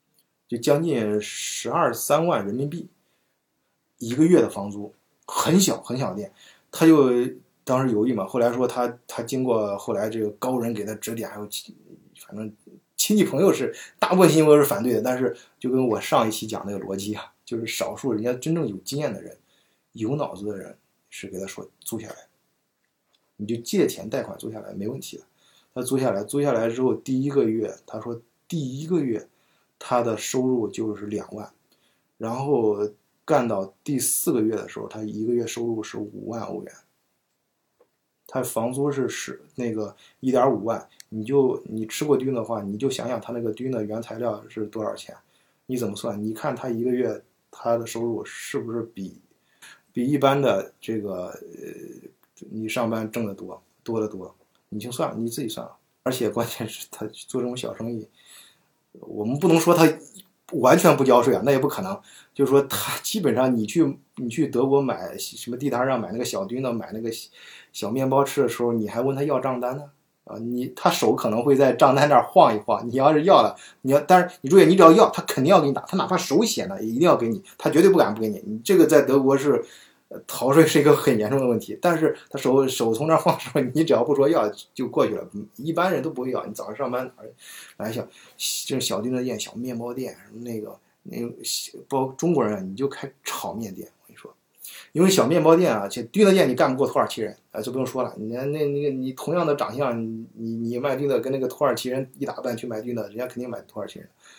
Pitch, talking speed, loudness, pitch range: 125 Hz, 300 characters per minute, -23 LUFS, 115-145 Hz